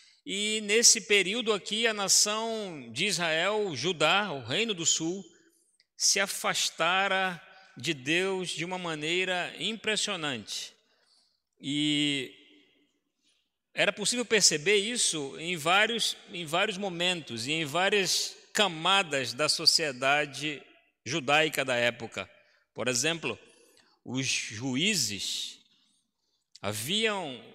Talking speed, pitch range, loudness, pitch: 100 wpm, 150-210 Hz, -27 LUFS, 180 Hz